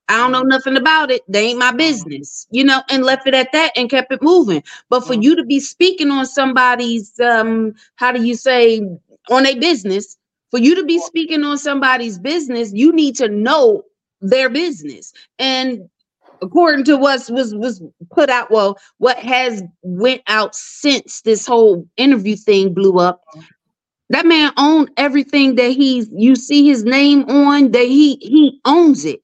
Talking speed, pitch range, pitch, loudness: 180 wpm, 225-285 Hz, 255 Hz, -13 LUFS